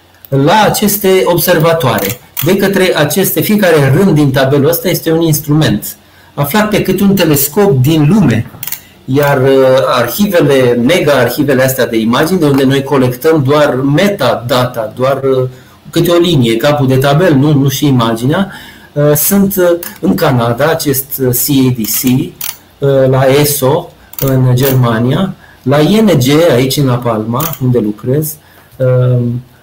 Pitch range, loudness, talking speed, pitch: 125-160 Hz, -10 LUFS, 125 wpm, 140 Hz